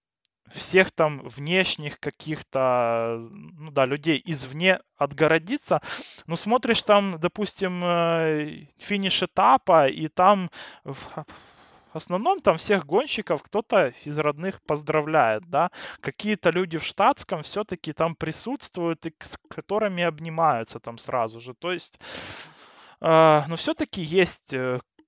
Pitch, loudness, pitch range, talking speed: 165 Hz, -24 LUFS, 150-185 Hz, 110 wpm